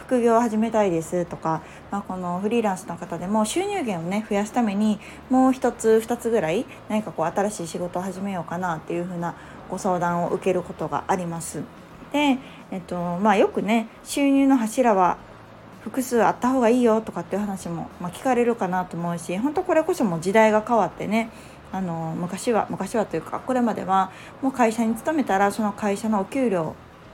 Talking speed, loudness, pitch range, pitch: 385 characters per minute, -23 LUFS, 180-235 Hz, 205 Hz